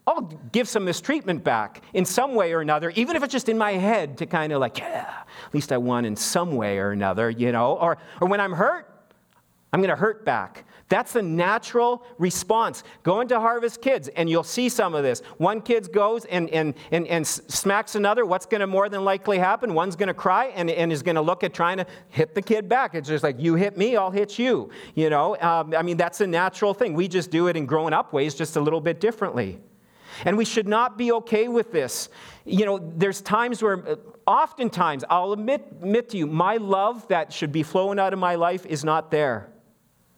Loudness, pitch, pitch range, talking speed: -23 LUFS, 185 Hz, 160-220 Hz, 225 wpm